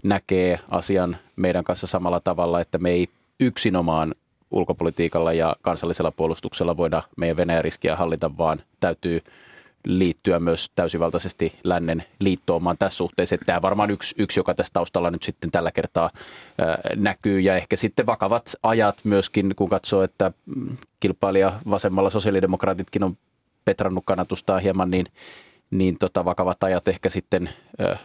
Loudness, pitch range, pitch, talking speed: -23 LUFS, 85-95 Hz, 95 Hz, 145 wpm